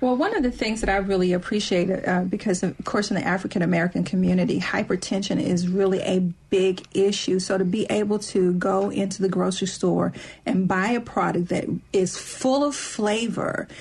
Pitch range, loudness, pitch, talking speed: 185-210 Hz, -23 LUFS, 195 Hz, 185 wpm